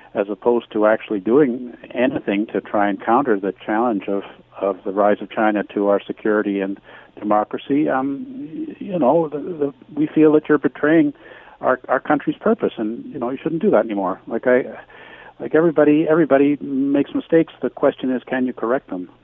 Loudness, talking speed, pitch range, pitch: -19 LUFS, 185 wpm, 105-160 Hz, 130 Hz